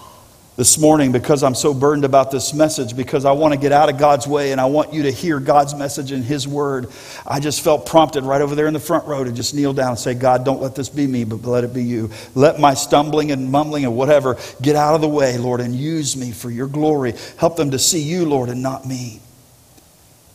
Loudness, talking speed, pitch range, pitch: -17 LUFS, 250 wpm, 125-150 Hz, 140 Hz